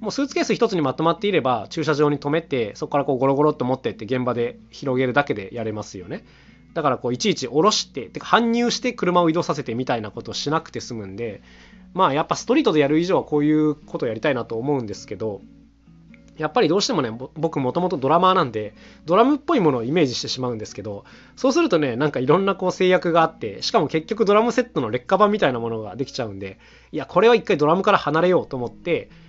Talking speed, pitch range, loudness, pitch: 515 characters per minute, 125-180 Hz, -21 LUFS, 150 Hz